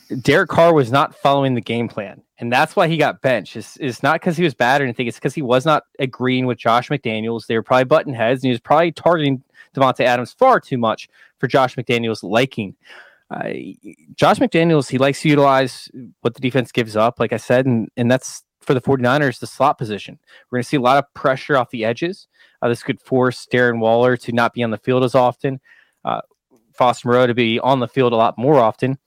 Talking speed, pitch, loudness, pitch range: 230 wpm, 130 Hz, -17 LUFS, 120-140 Hz